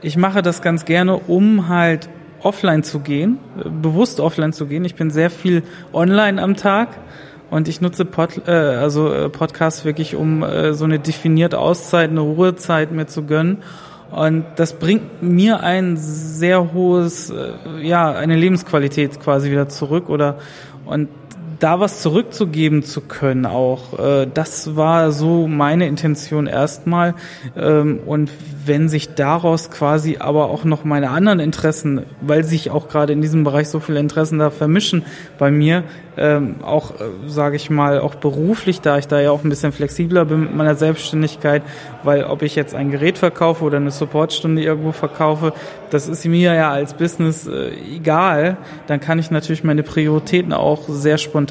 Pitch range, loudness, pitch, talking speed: 150-170 Hz, -17 LUFS, 155 Hz, 160 wpm